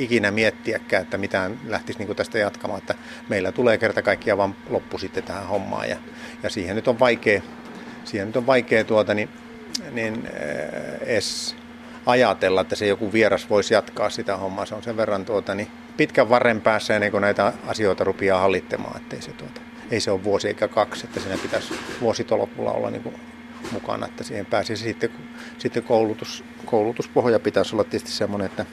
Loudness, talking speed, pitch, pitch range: -23 LUFS, 180 wpm, 110 Hz, 105-125 Hz